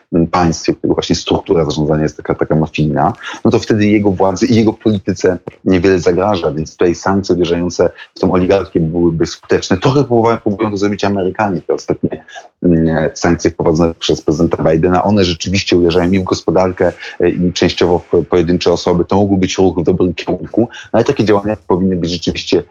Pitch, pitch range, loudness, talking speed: 95 Hz, 85-100 Hz, -14 LUFS, 180 wpm